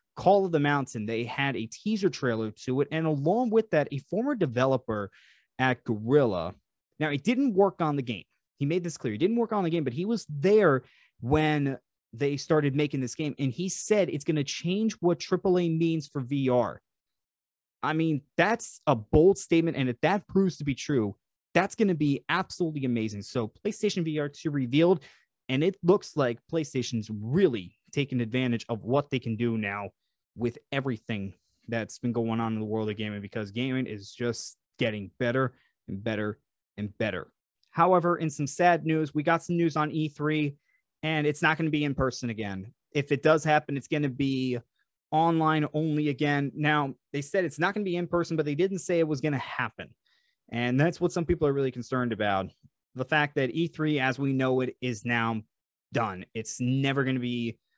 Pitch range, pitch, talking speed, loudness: 120-165 Hz, 140 Hz, 200 wpm, -28 LUFS